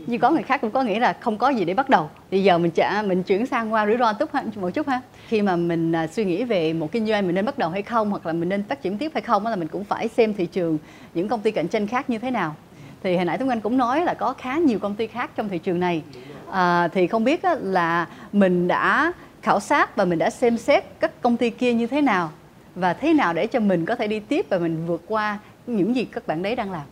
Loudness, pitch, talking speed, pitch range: -22 LUFS, 215 Hz, 290 wpm, 180-245 Hz